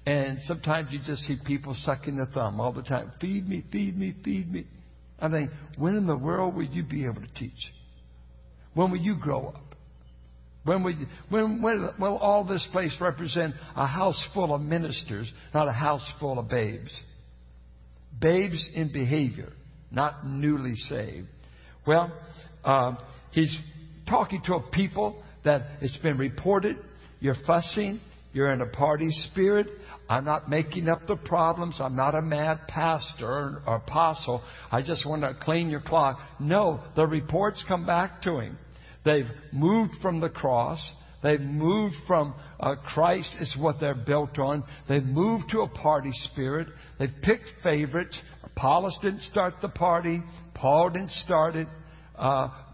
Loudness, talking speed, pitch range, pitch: -27 LUFS, 160 wpm, 135-170 Hz, 150 Hz